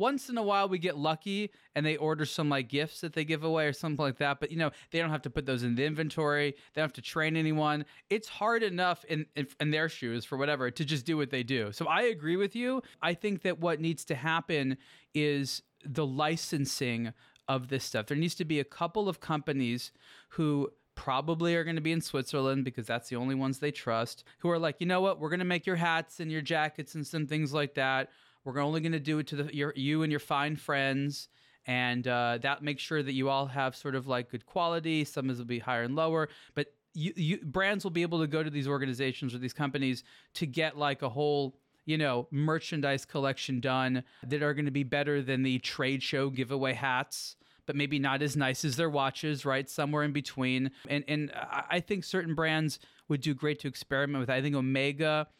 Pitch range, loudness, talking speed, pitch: 135-160 Hz, -32 LUFS, 235 wpm, 145 Hz